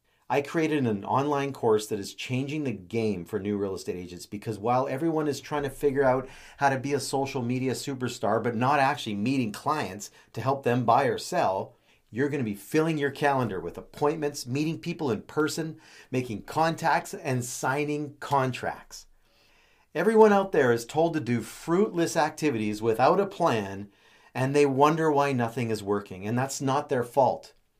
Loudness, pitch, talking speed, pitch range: -27 LUFS, 135 Hz, 180 wpm, 115-150 Hz